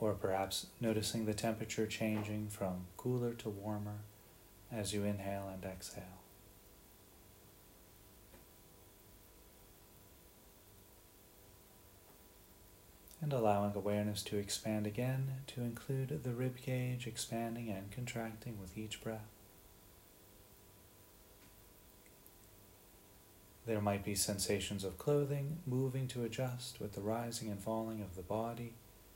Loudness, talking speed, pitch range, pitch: -40 LUFS, 100 wpm, 100-115 Hz, 105 Hz